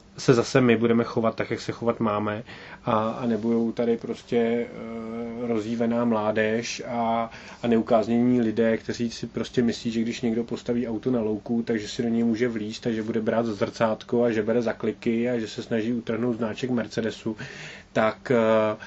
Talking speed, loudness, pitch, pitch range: 170 wpm, -25 LUFS, 115 Hz, 110-120 Hz